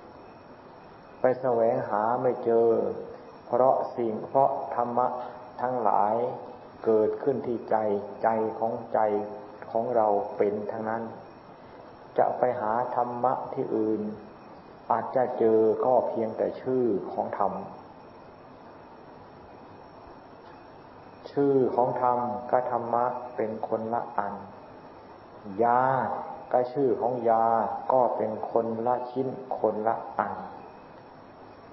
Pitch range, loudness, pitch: 110-125 Hz, -27 LUFS, 120 Hz